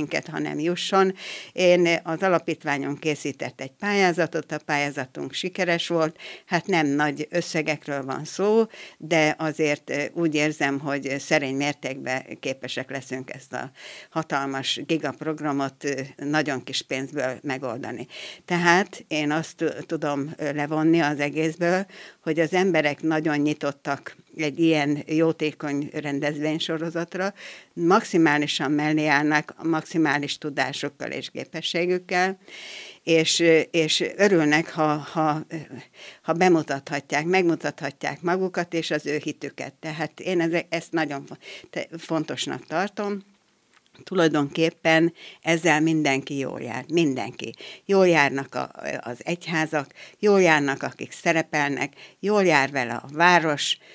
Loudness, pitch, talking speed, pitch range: -24 LUFS, 155 Hz, 110 wpm, 145-170 Hz